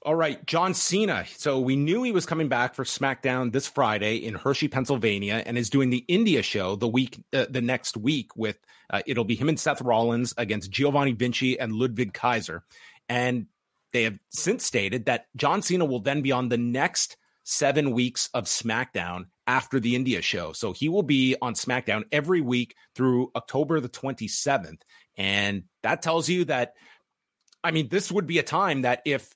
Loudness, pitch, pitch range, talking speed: -25 LUFS, 130 Hz, 120-150 Hz, 190 wpm